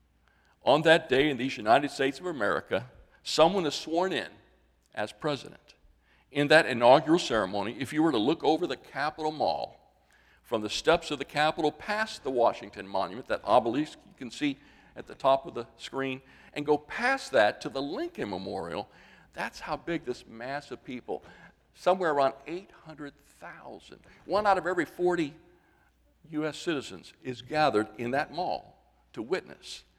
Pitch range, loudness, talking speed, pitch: 125-170 Hz, -28 LUFS, 160 wpm, 150 Hz